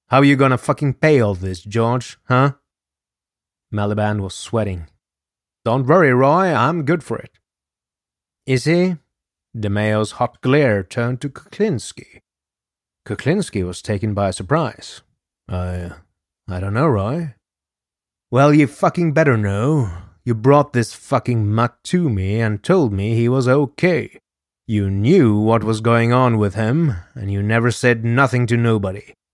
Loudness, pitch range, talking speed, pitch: -18 LUFS, 100-140 Hz, 145 wpm, 115 Hz